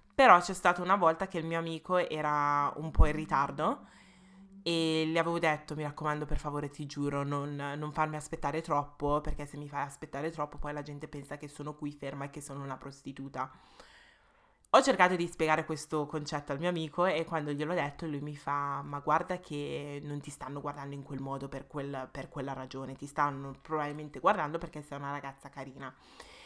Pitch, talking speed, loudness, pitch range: 150 Hz, 200 wpm, -33 LUFS, 140-160 Hz